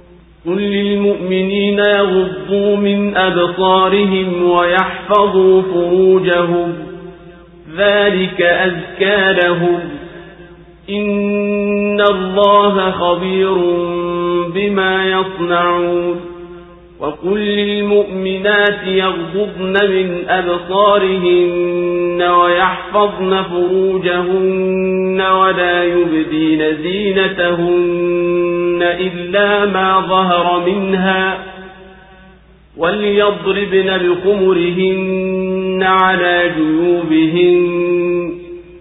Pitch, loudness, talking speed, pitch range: 185 Hz, -14 LUFS, 50 wpm, 175-190 Hz